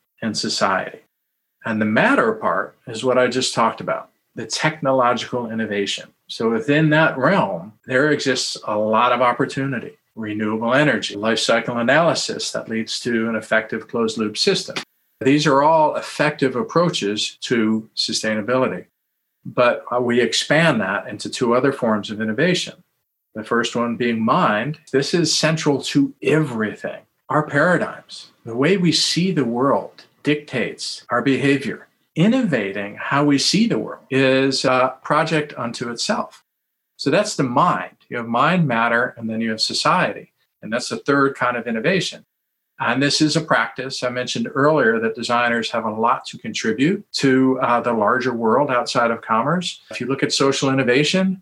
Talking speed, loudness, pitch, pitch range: 160 wpm, -19 LUFS, 130 Hz, 115-150 Hz